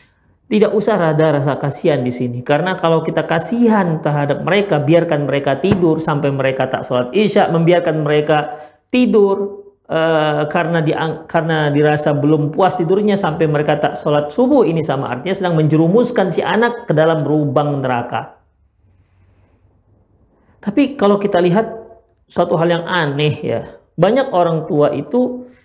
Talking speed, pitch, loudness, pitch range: 145 wpm, 160 Hz, -15 LUFS, 145-190 Hz